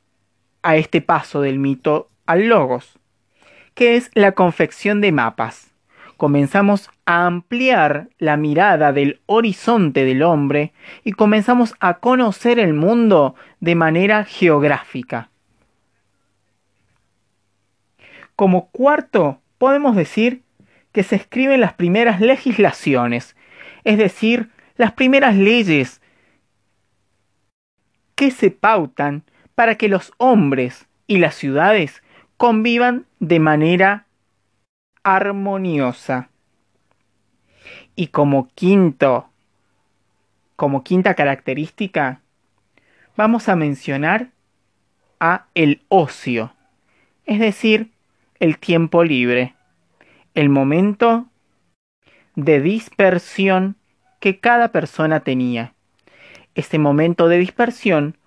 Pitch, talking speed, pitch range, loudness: 170 Hz, 90 wpm, 130-215 Hz, -16 LUFS